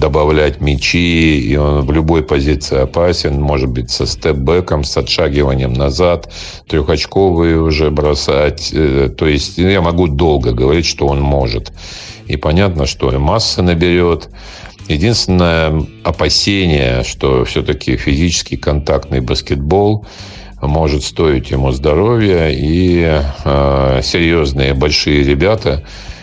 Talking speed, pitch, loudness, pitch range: 110 wpm, 75 Hz, -13 LUFS, 70-85 Hz